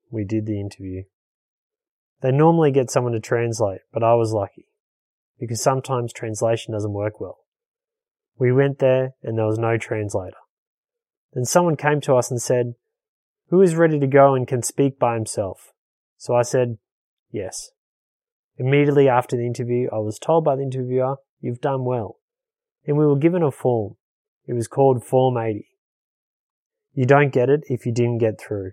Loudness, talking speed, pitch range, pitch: -20 LUFS, 170 wpm, 115-150 Hz, 130 Hz